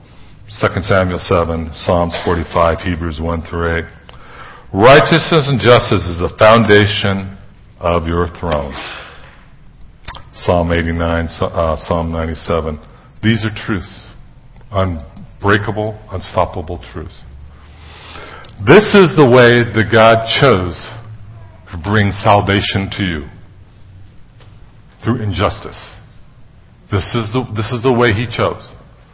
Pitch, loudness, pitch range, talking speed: 100 Hz, -13 LUFS, 85-110 Hz, 110 wpm